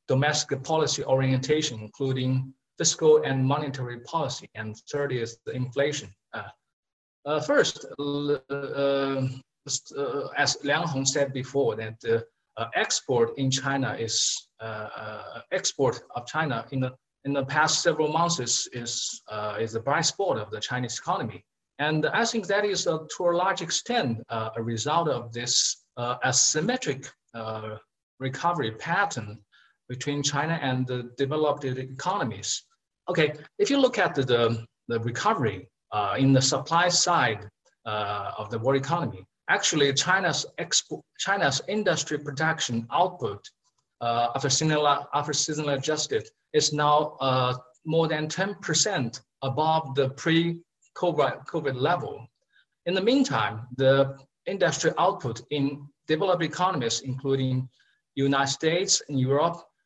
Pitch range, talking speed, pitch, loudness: 125-160 Hz, 135 wpm, 140 Hz, -26 LUFS